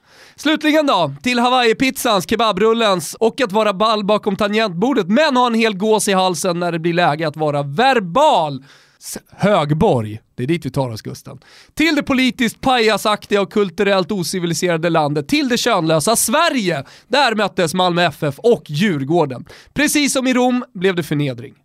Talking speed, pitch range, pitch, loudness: 165 wpm, 170-245 Hz, 210 Hz, -16 LUFS